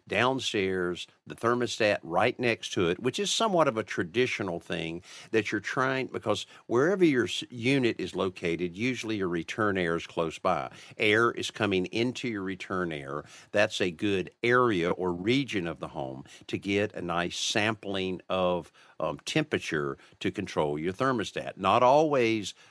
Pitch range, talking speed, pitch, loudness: 90-120 Hz, 160 wpm, 105 Hz, -28 LUFS